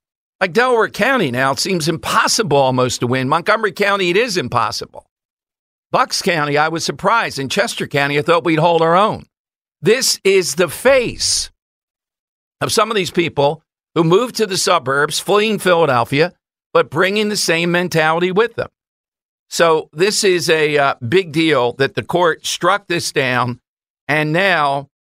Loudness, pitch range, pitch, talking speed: -15 LUFS, 145-190 Hz, 170 Hz, 160 wpm